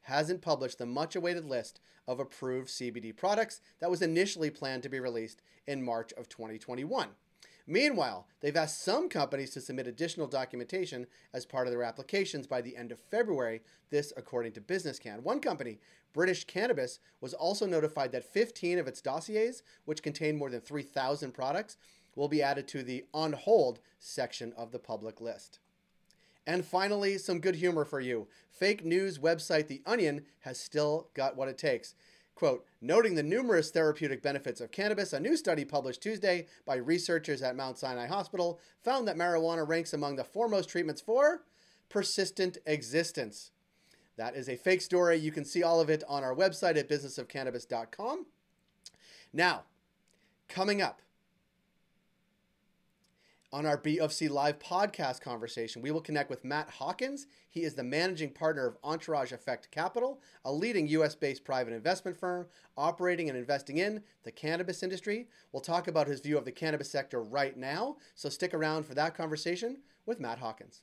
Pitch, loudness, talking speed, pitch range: 155 Hz, -33 LUFS, 165 wpm, 135-185 Hz